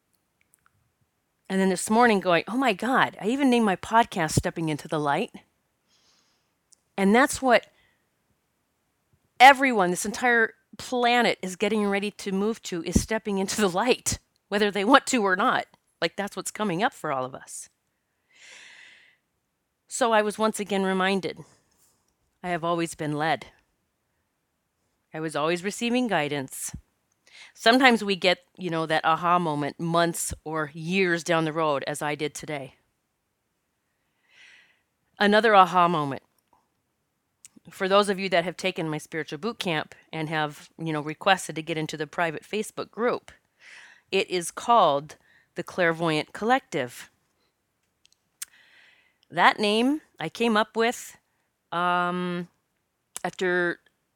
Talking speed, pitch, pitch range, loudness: 135 wpm, 180 Hz, 160-215 Hz, -24 LUFS